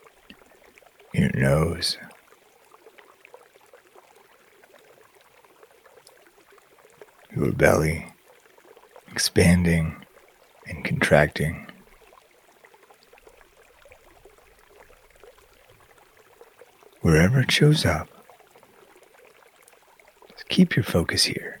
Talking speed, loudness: 40 wpm, -22 LUFS